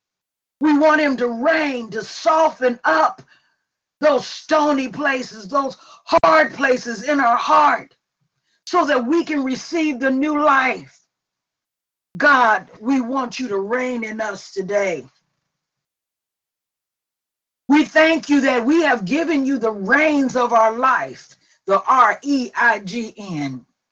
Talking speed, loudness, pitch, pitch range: 135 wpm, -18 LUFS, 260 Hz, 225-295 Hz